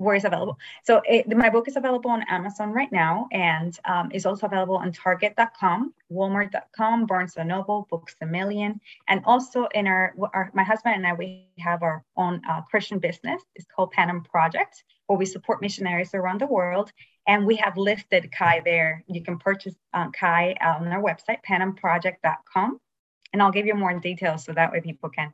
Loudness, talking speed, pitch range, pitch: -24 LUFS, 190 wpm, 175-210 Hz, 190 Hz